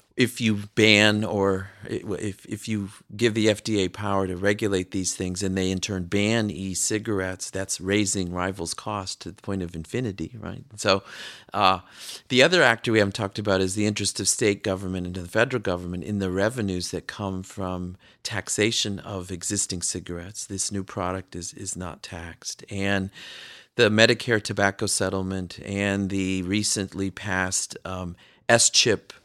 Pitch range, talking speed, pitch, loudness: 95-105 Hz, 165 wpm, 100 Hz, -24 LUFS